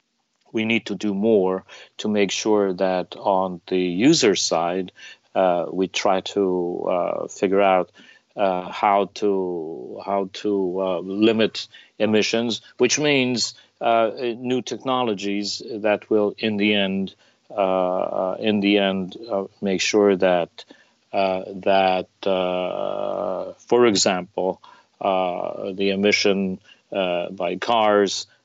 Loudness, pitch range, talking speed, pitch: -22 LUFS, 95-105 Hz, 120 wpm, 100 Hz